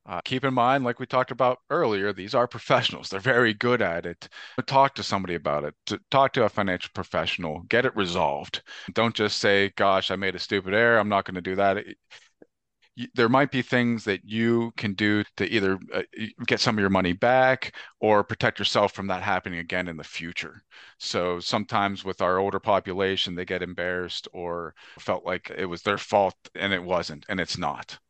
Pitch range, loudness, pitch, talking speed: 90-120 Hz, -25 LUFS, 100 Hz, 200 wpm